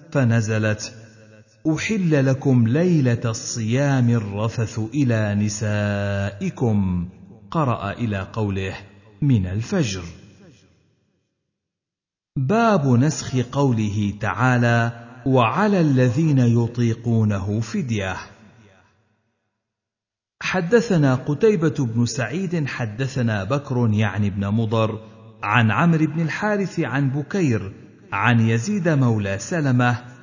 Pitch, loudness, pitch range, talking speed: 115 Hz, -21 LUFS, 110-140 Hz, 80 wpm